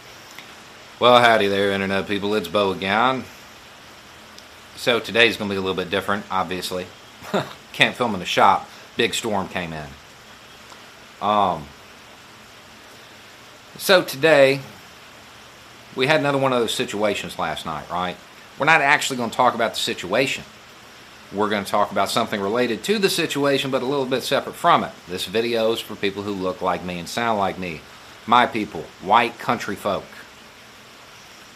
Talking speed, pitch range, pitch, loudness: 160 wpm, 95-125 Hz, 100 Hz, -21 LUFS